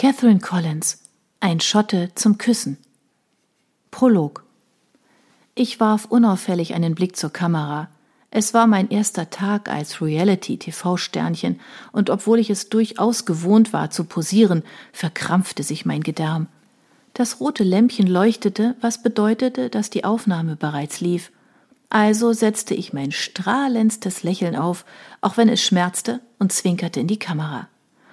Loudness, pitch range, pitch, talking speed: -20 LUFS, 175-225 Hz, 205 Hz, 130 wpm